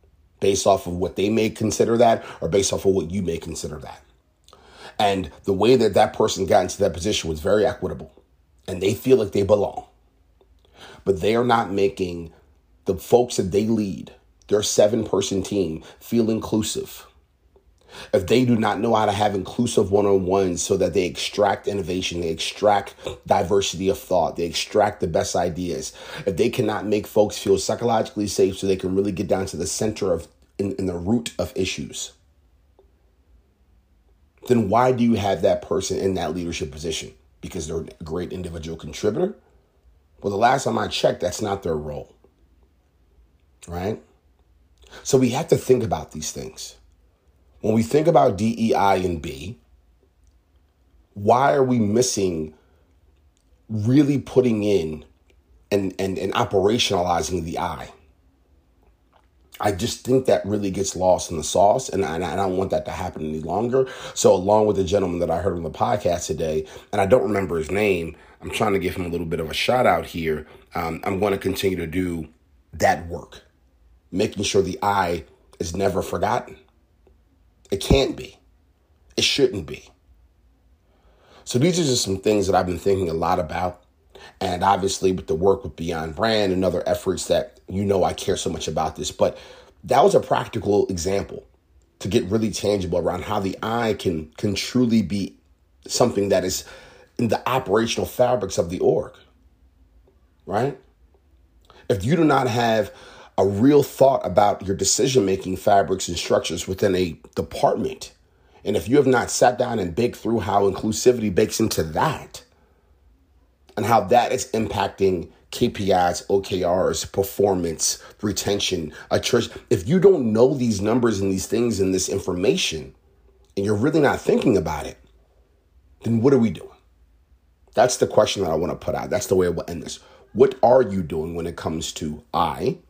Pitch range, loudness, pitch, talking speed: 80-105 Hz, -22 LUFS, 95 Hz, 175 wpm